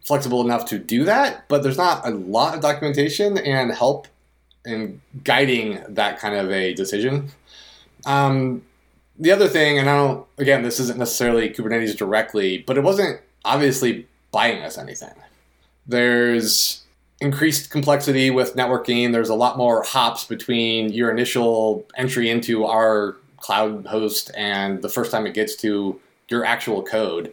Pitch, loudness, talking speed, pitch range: 120 Hz, -20 LUFS, 150 wpm, 110-135 Hz